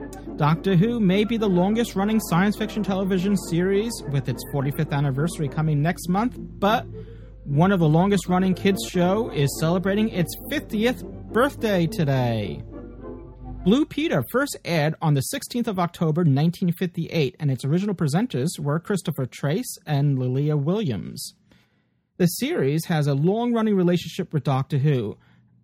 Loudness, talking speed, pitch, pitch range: -23 LUFS, 145 wpm, 170 Hz, 145-195 Hz